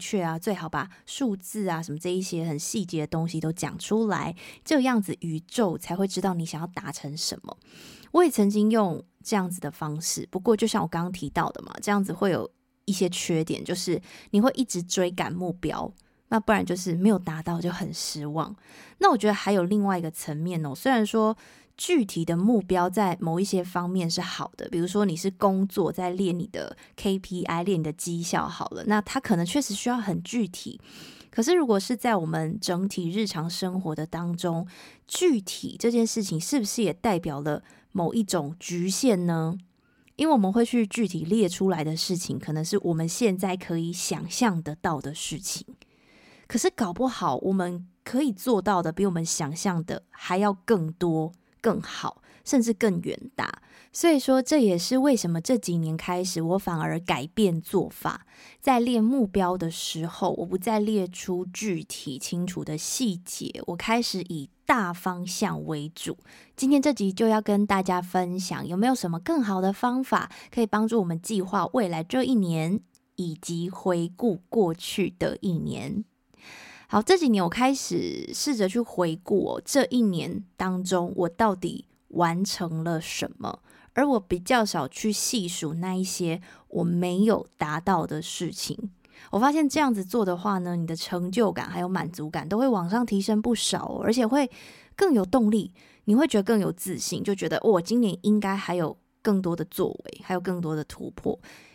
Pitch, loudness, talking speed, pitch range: 185 Hz, -26 LUFS, 270 characters per minute, 170-220 Hz